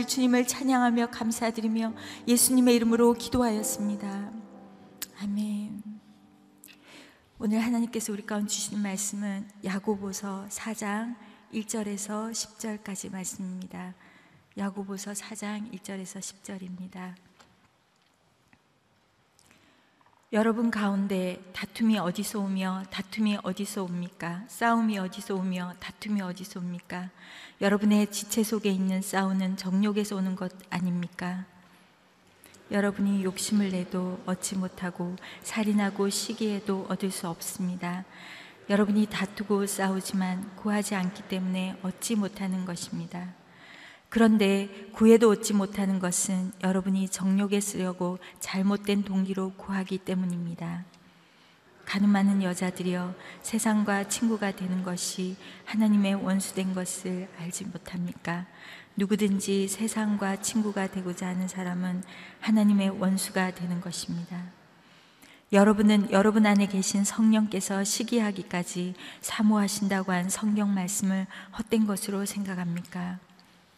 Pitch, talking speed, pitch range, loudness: 195 Hz, 275 characters per minute, 185-210 Hz, -28 LUFS